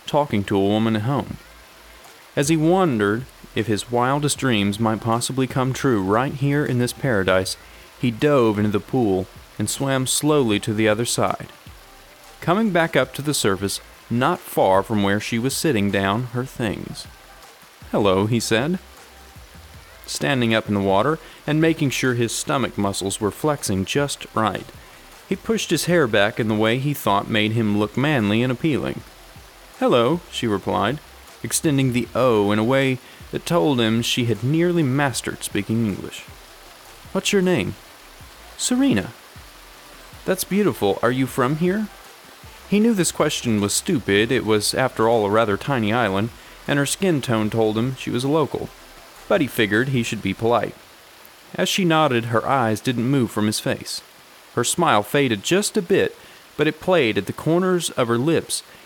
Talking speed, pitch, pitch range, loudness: 170 wpm, 120 Hz, 105-150 Hz, -21 LUFS